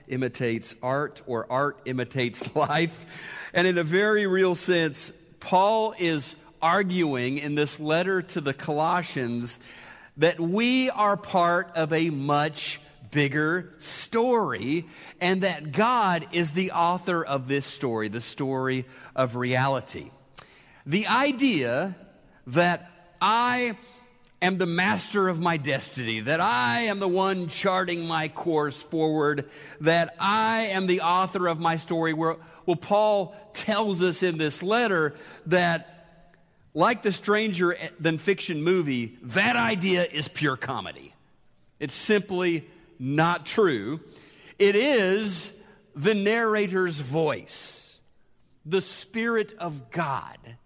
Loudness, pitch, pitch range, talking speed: -25 LUFS, 170 Hz, 150-190 Hz, 120 wpm